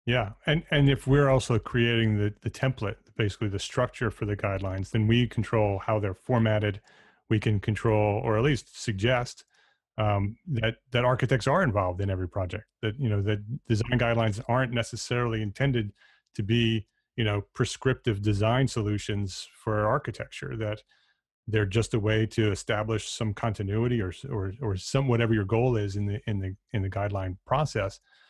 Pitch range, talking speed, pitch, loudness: 105-120 Hz, 170 wpm, 110 Hz, -28 LUFS